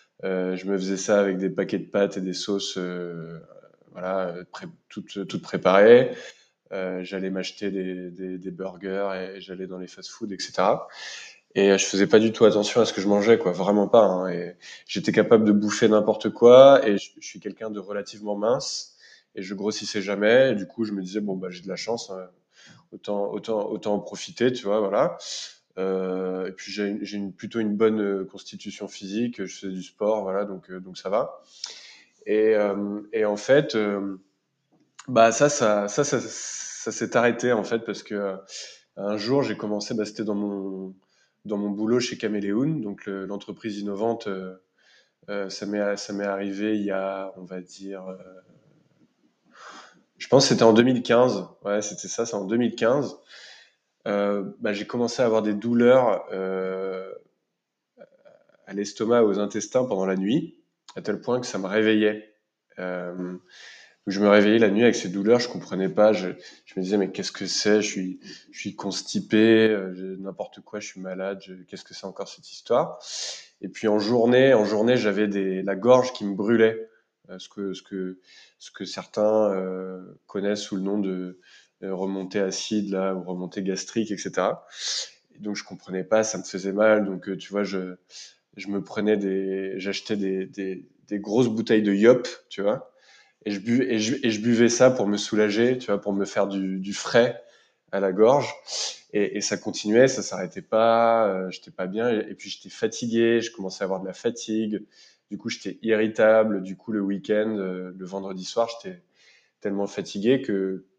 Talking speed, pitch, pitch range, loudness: 190 wpm, 100 Hz, 95-110 Hz, -24 LUFS